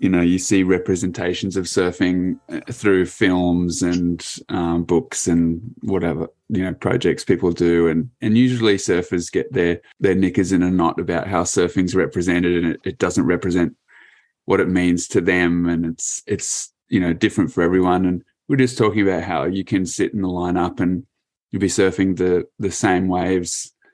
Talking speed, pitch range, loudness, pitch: 180 wpm, 85-95 Hz, -19 LUFS, 90 Hz